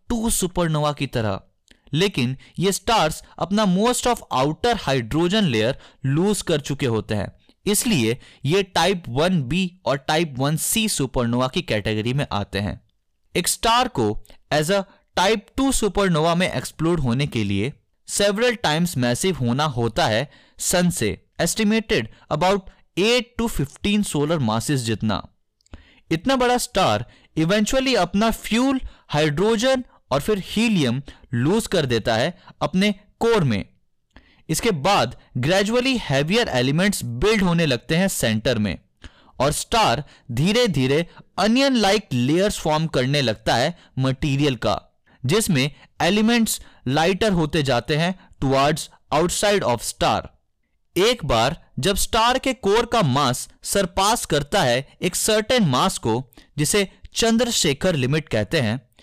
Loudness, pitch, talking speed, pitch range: -21 LUFS, 160 Hz, 135 wpm, 130-205 Hz